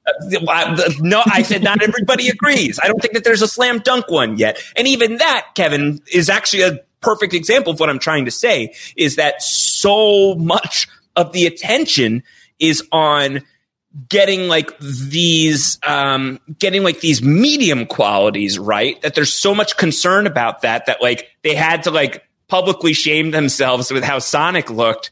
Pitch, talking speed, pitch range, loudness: 165 Hz, 165 wpm, 145-205 Hz, -14 LUFS